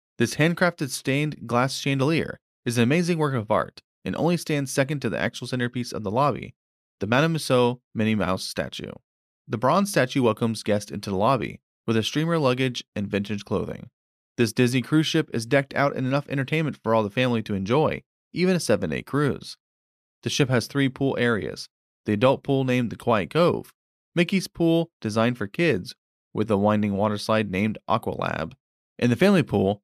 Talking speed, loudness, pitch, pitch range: 185 wpm, -24 LUFS, 125 Hz, 110-145 Hz